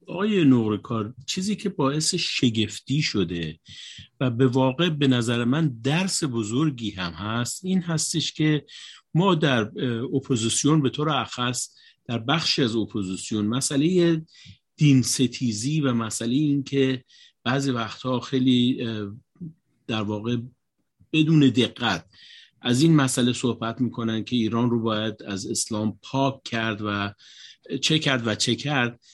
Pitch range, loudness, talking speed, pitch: 115-150 Hz, -24 LUFS, 130 wpm, 125 Hz